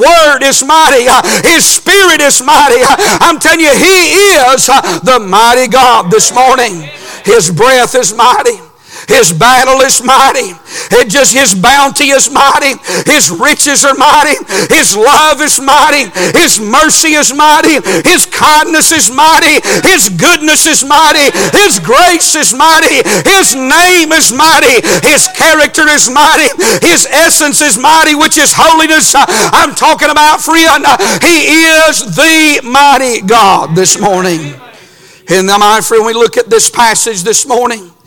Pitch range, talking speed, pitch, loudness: 250-320 Hz, 145 wpm, 295 Hz, -5 LUFS